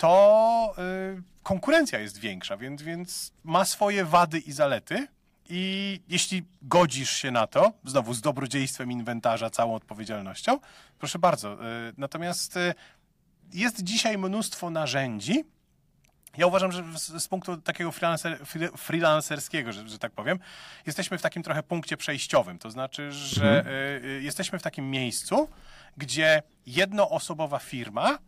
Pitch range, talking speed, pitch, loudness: 135-185 Hz, 120 wpm, 165 Hz, -27 LUFS